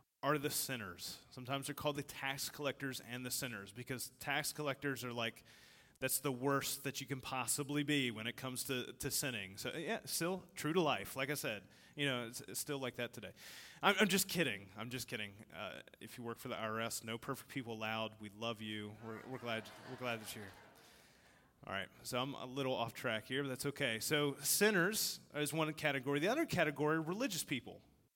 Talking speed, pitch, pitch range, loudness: 210 wpm, 130 Hz, 115-145 Hz, -39 LUFS